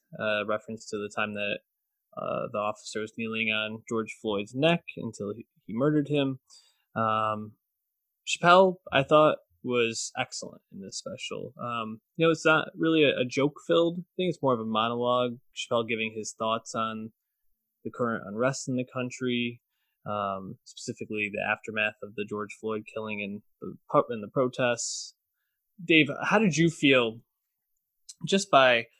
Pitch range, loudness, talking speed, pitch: 110-145 Hz, -28 LUFS, 160 wpm, 115 Hz